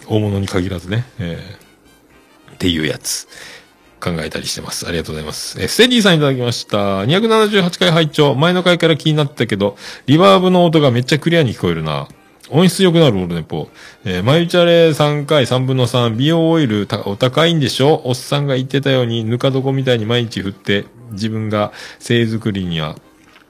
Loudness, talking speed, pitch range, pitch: -15 LUFS, 375 characters per minute, 105-160 Hz, 130 Hz